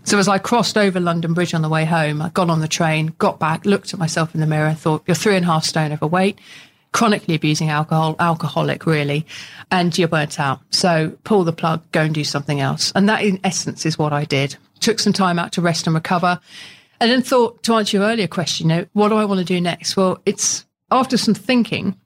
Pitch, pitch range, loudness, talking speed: 170 Hz, 160-200 Hz, -18 LUFS, 240 wpm